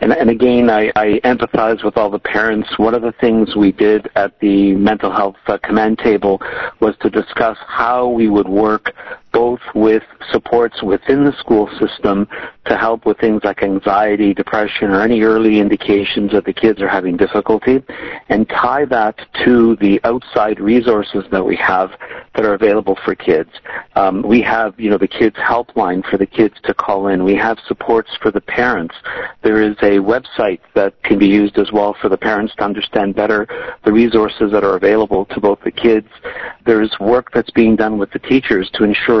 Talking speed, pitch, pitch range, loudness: 185 wpm, 110 Hz, 100-115 Hz, -14 LUFS